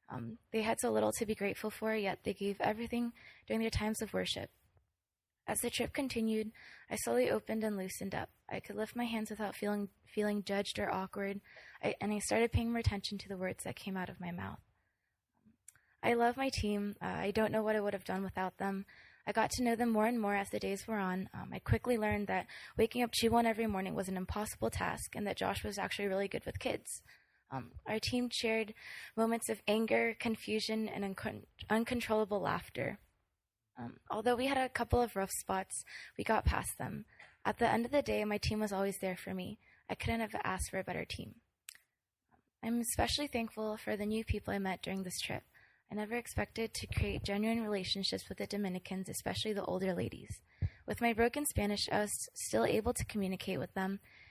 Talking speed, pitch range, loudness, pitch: 210 wpm, 190-225 Hz, -37 LUFS, 210 Hz